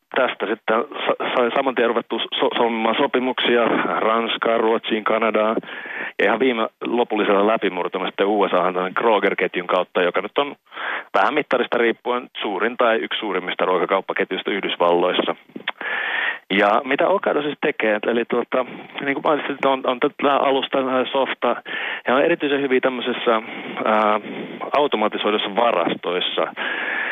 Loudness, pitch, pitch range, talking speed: -20 LUFS, 115 Hz, 110-130 Hz, 125 wpm